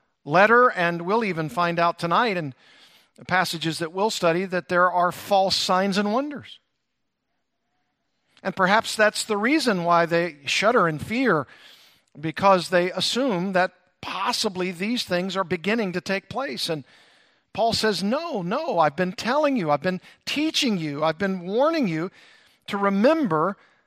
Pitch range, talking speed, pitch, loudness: 175-220 Hz, 155 wpm, 190 Hz, -23 LUFS